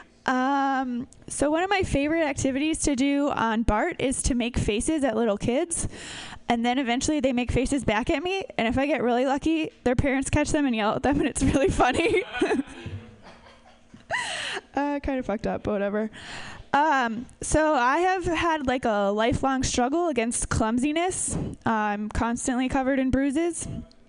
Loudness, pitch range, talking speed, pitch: -25 LUFS, 235-305 Hz, 170 wpm, 265 Hz